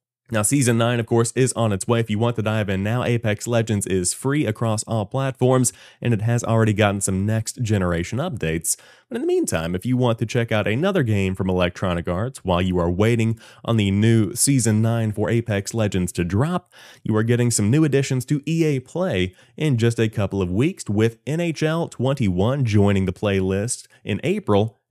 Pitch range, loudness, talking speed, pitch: 100-125 Hz, -21 LUFS, 200 wpm, 115 Hz